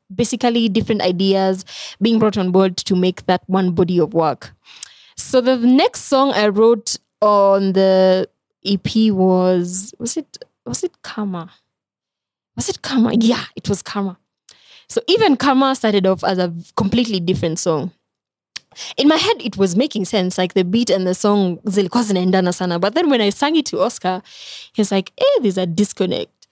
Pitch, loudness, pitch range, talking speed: 200 Hz, -17 LUFS, 185-235 Hz, 165 wpm